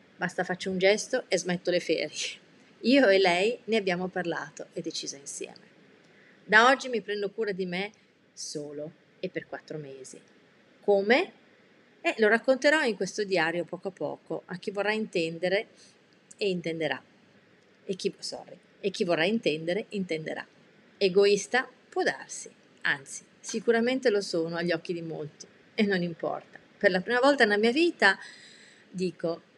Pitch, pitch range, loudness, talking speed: 195 Hz, 175-225 Hz, -28 LUFS, 155 wpm